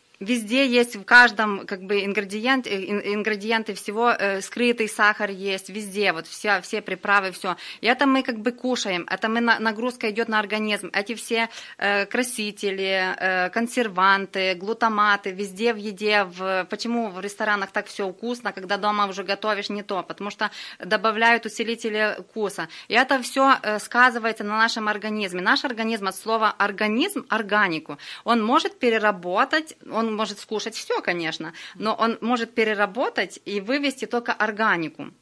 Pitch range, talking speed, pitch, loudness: 200-230 Hz, 155 wpm, 215 Hz, -23 LUFS